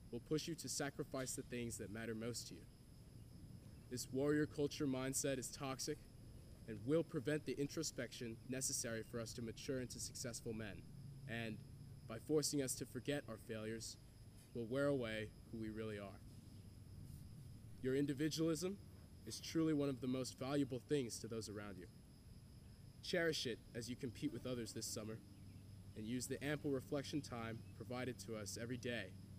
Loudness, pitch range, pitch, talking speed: -45 LUFS, 110-140 Hz, 120 Hz, 165 wpm